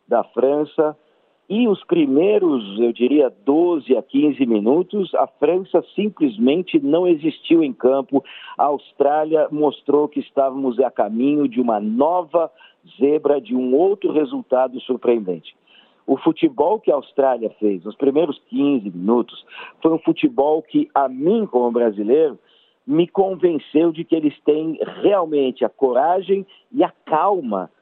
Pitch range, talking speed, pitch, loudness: 135-215 Hz, 140 wpm, 155 Hz, -19 LUFS